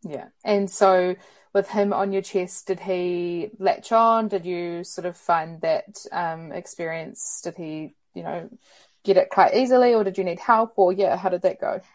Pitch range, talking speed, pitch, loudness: 175-205 Hz, 195 wpm, 190 Hz, -23 LUFS